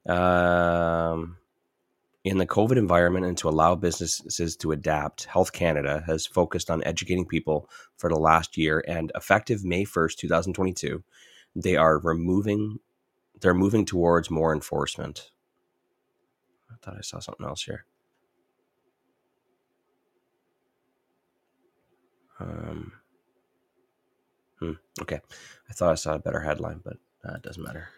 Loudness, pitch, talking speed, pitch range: -25 LUFS, 85 Hz, 130 wpm, 80-95 Hz